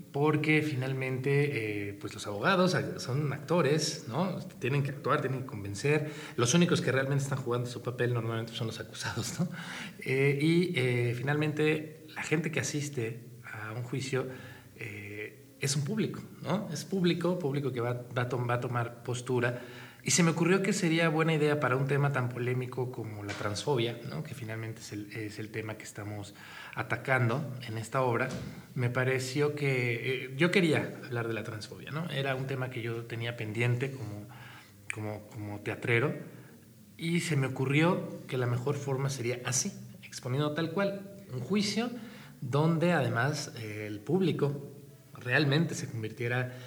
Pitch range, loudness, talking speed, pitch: 120-150 Hz, -31 LUFS, 165 wpm, 130 Hz